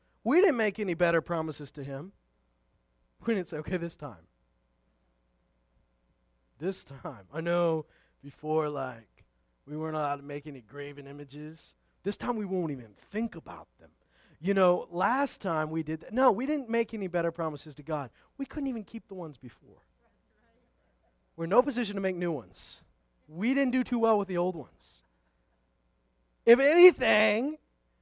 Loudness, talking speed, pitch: -29 LUFS, 165 wpm, 155 Hz